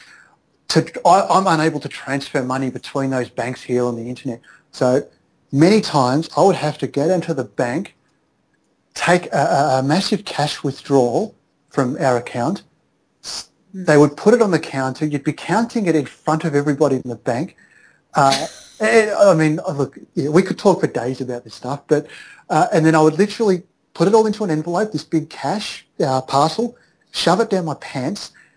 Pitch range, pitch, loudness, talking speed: 135-180 Hz, 155 Hz, -18 LUFS, 185 wpm